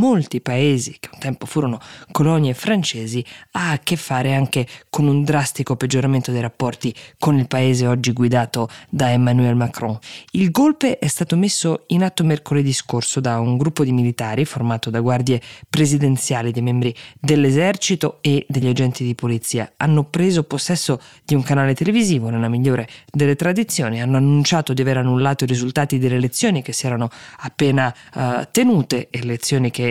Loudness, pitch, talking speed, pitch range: -19 LUFS, 135 Hz, 165 wpm, 125-150 Hz